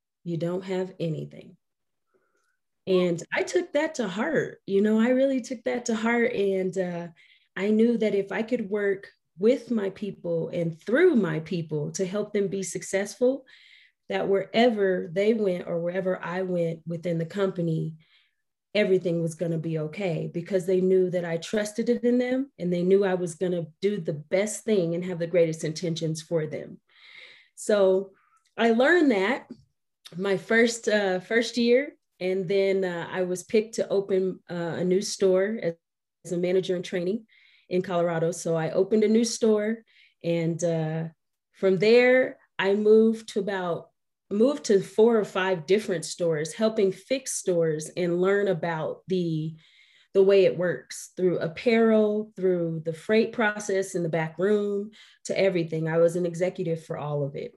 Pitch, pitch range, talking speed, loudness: 190 Hz, 170-215 Hz, 170 wpm, -26 LUFS